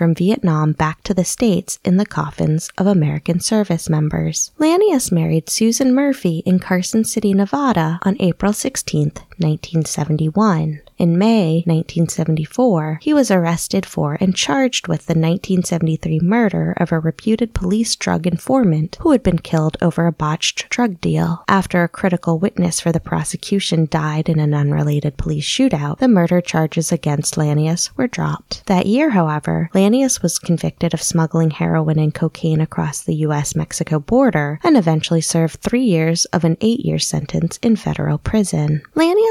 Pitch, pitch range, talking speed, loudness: 170 Hz, 160-200 Hz, 155 wpm, -17 LUFS